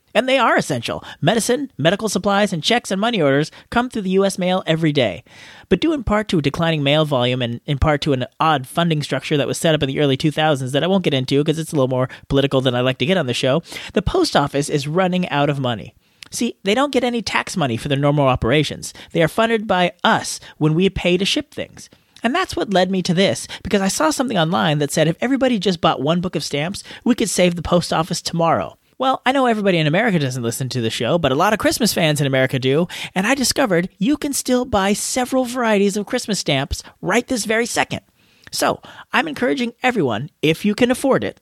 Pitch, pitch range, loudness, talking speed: 175 Hz, 145-225 Hz, -18 LUFS, 240 wpm